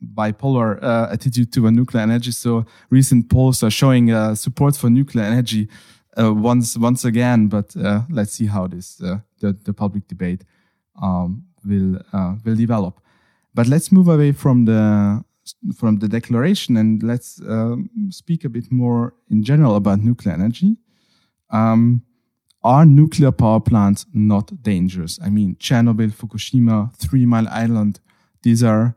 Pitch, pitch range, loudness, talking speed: 115 Hz, 105-125 Hz, -17 LUFS, 155 wpm